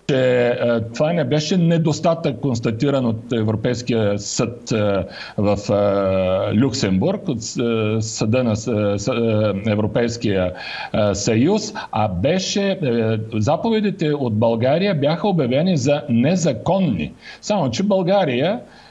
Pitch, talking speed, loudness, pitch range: 125 Hz, 90 wpm, -19 LUFS, 110-165 Hz